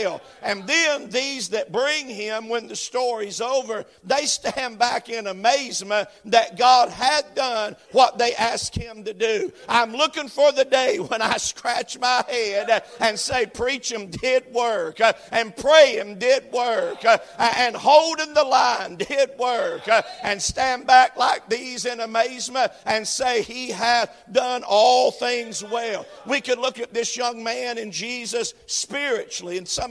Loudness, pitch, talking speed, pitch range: -21 LUFS, 245 Hz, 160 wpm, 230-275 Hz